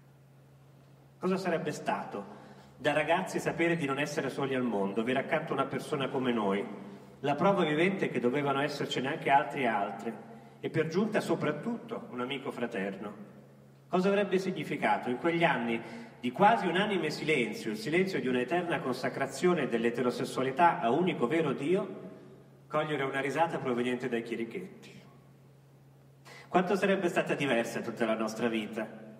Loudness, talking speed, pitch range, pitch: -31 LUFS, 140 wpm, 120-165 Hz, 140 Hz